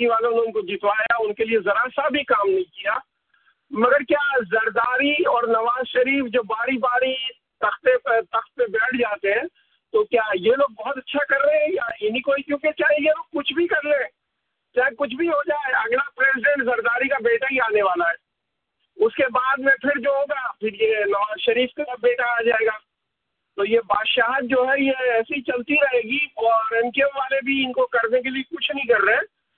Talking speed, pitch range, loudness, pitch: 215 wpm, 230-290 Hz, -21 LUFS, 265 Hz